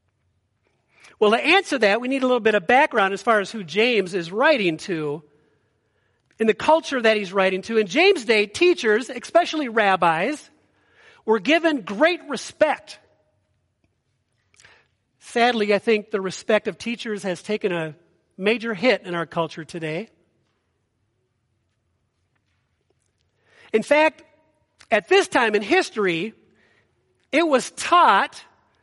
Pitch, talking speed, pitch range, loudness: 215 Hz, 130 wpm, 170-275 Hz, -20 LUFS